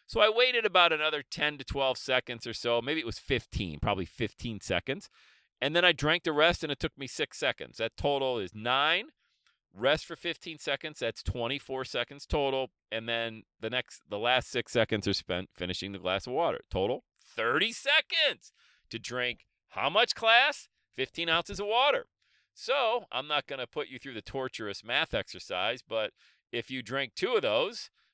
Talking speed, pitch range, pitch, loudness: 190 wpm, 115-165 Hz, 130 Hz, -30 LUFS